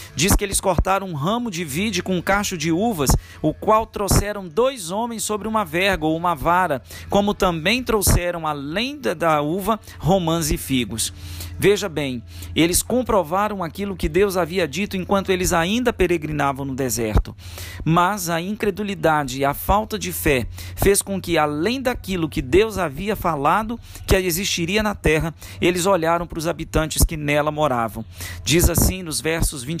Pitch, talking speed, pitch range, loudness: 175 Hz, 165 wpm, 150-200 Hz, -21 LUFS